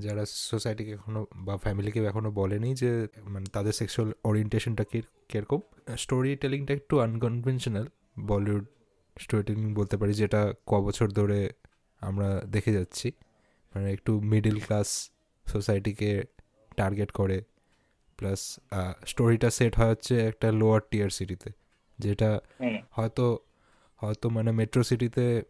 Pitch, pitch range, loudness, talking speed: 110 Hz, 105-115 Hz, -29 LUFS, 120 wpm